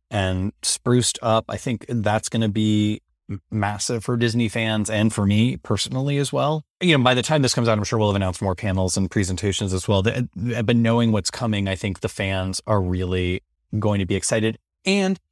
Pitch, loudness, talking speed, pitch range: 110 Hz, -22 LUFS, 210 wpm, 100-120 Hz